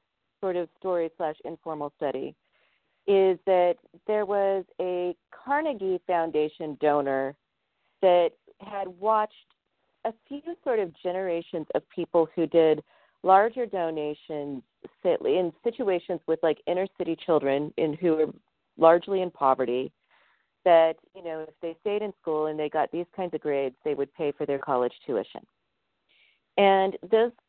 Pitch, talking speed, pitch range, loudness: 170 Hz, 140 wpm, 155-195 Hz, -27 LUFS